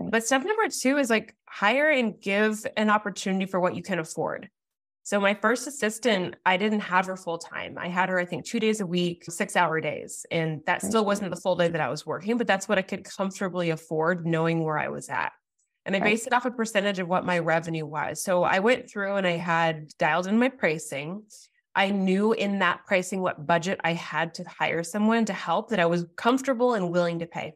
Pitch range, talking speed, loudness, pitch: 170-215 Hz, 230 wpm, -26 LUFS, 190 Hz